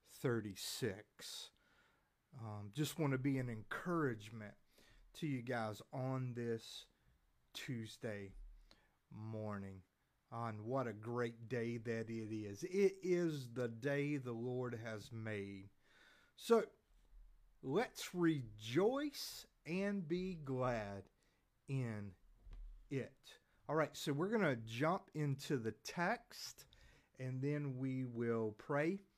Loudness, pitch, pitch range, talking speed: -42 LUFS, 125 Hz, 110-150 Hz, 115 wpm